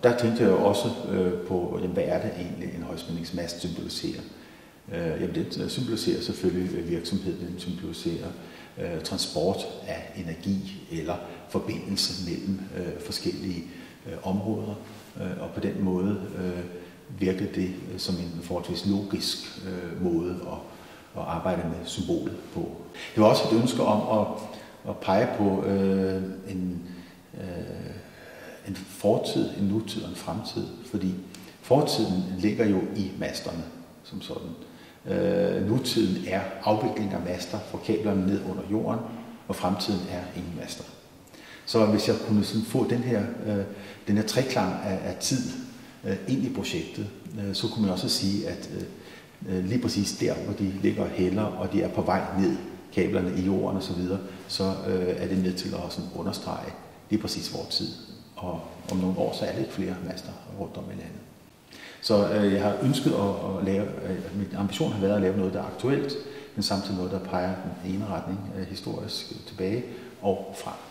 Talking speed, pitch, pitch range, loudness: 170 wpm, 95 Hz, 90-105 Hz, -28 LUFS